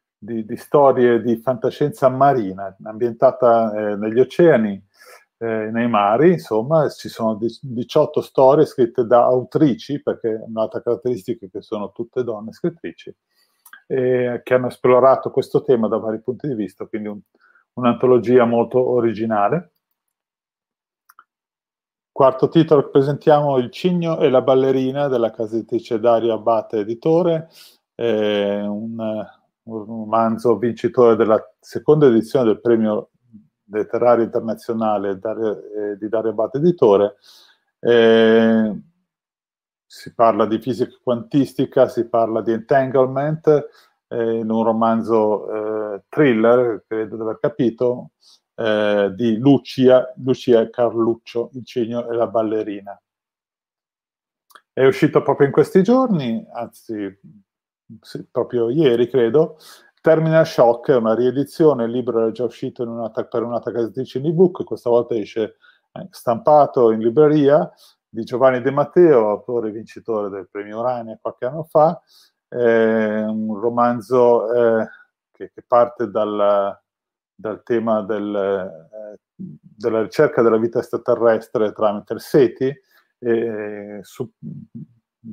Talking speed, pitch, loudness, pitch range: 125 wpm, 120 Hz, -18 LUFS, 110-135 Hz